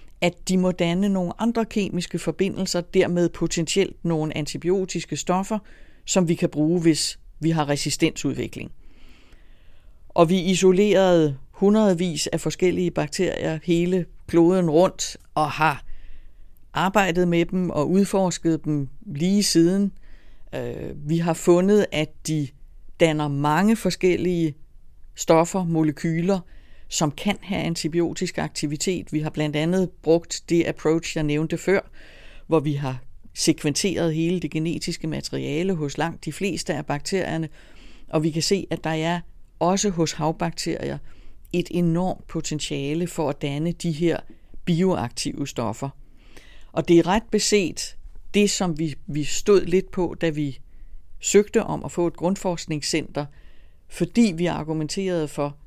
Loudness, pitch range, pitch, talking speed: -23 LUFS, 150-185 Hz, 165 Hz, 135 wpm